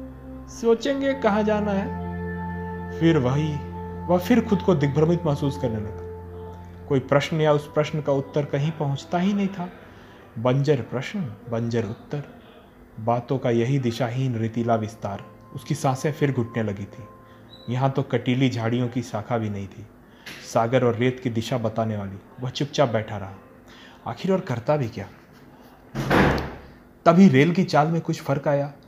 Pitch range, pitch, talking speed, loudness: 110-150 Hz, 125 Hz, 160 wpm, -24 LUFS